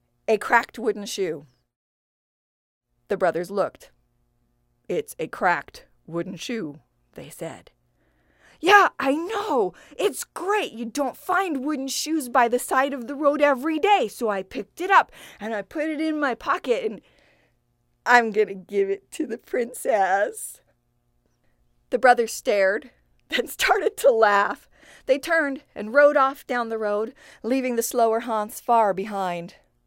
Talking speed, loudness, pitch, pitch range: 150 wpm, -23 LUFS, 235 Hz, 180-290 Hz